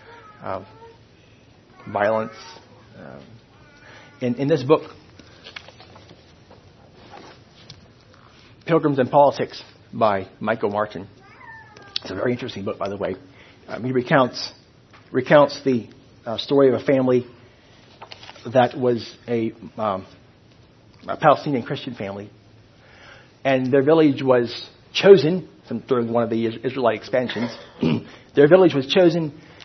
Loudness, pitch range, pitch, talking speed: -20 LUFS, 115-145 Hz, 125 Hz, 110 wpm